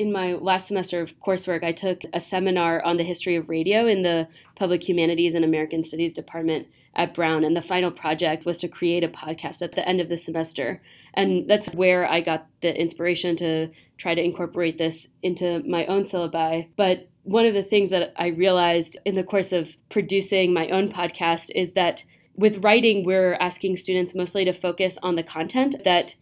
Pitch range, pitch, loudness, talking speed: 165-185 Hz, 175 Hz, -23 LUFS, 195 wpm